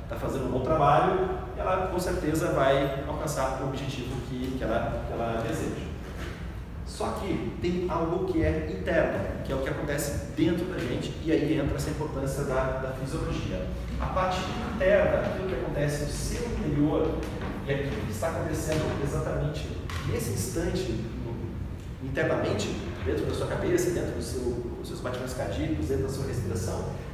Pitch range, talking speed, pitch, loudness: 130-150 Hz, 165 wpm, 135 Hz, -29 LUFS